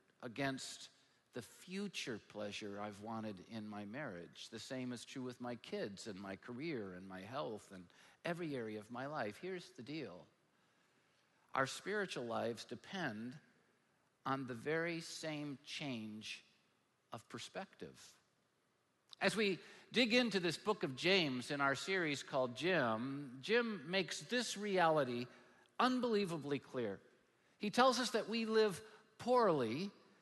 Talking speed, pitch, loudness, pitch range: 135 wpm, 140 Hz, -40 LUFS, 120-195 Hz